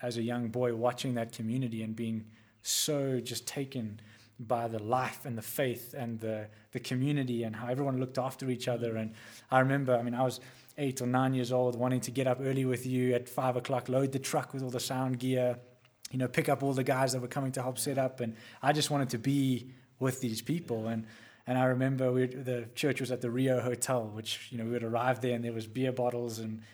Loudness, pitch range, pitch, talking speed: -33 LUFS, 120-130 Hz, 125 Hz, 240 wpm